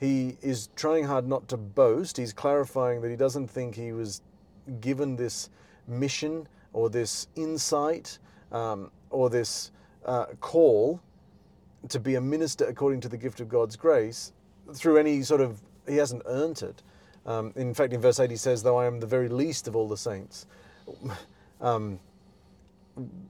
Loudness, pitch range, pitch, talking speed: -28 LUFS, 115-140 Hz, 125 Hz, 165 wpm